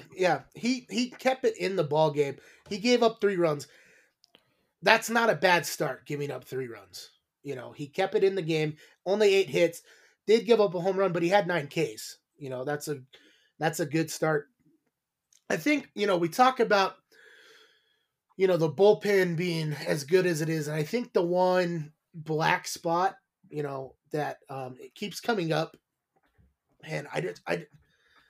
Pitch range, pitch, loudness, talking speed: 155-200 Hz, 175 Hz, -27 LUFS, 190 wpm